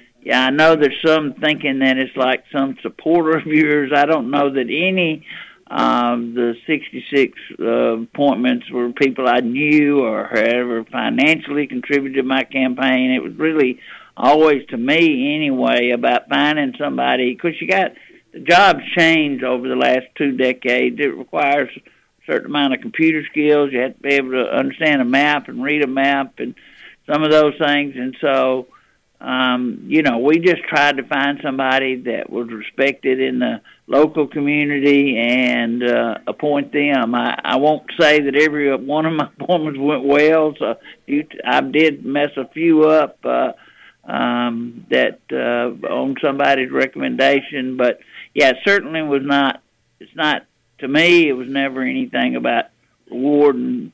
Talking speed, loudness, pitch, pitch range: 160 wpm, -17 LUFS, 140 Hz, 130-150 Hz